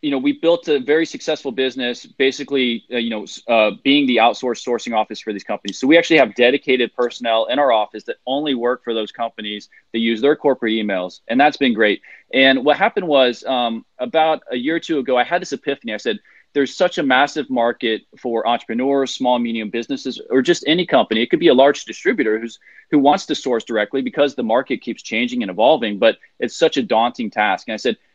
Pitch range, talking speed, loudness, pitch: 115-145 Hz, 220 wpm, -18 LUFS, 130 Hz